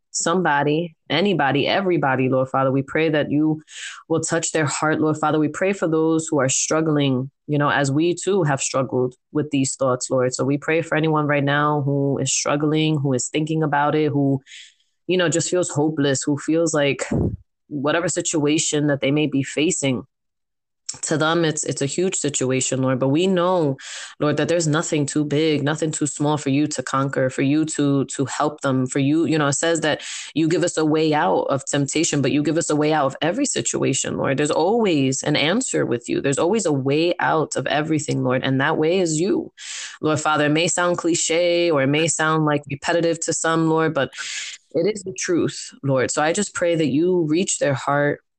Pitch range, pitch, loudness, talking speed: 140-165 Hz, 150 Hz, -20 LUFS, 210 wpm